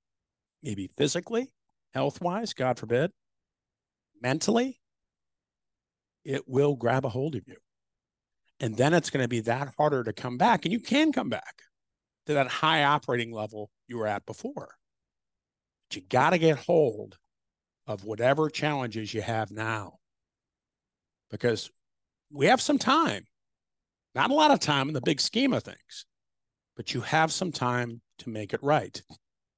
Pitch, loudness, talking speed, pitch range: 125 Hz, -27 LUFS, 155 wpm, 110-155 Hz